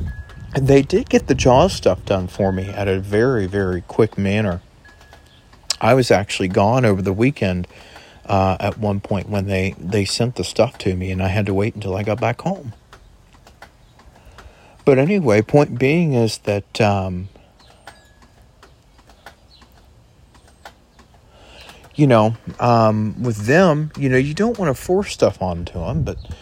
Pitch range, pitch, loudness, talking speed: 95-120 Hz, 105 Hz, -18 LUFS, 150 wpm